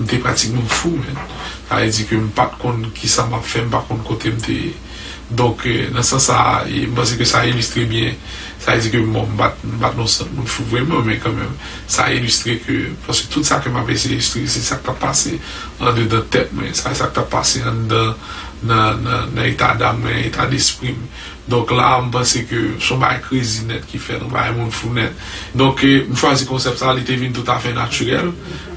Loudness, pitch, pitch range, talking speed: -16 LUFS, 120 Hz, 115-125 Hz, 250 wpm